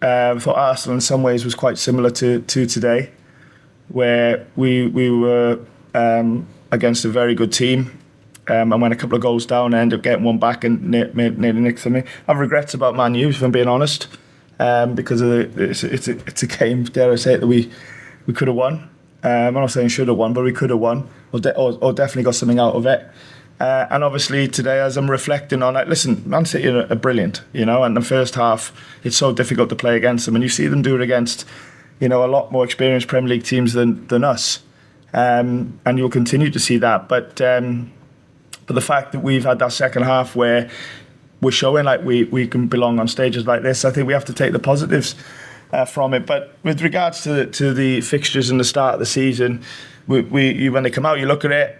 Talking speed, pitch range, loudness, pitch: 235 wpm, 120-135 Hz, -17 LUFS, 125 Hz